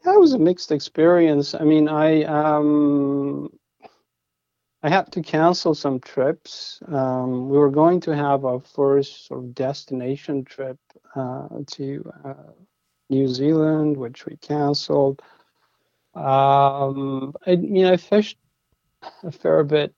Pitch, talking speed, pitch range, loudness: 145 Hz, 140 wpm, 135-160 Hz, -20 LUFS